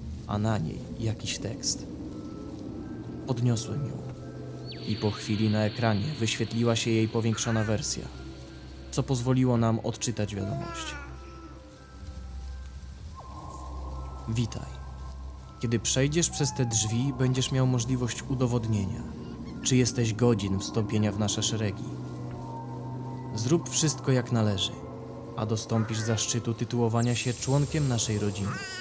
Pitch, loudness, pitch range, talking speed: 110 Hz, -28 LUFS, 75-120 Hz, 105 wpm